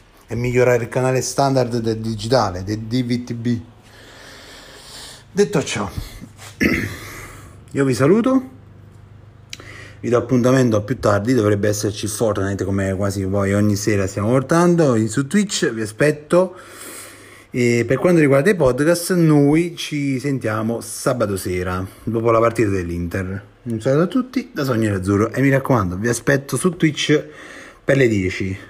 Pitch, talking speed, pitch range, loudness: 120 Hz, 135 wpm, 105-140 Hz, -18 LUFS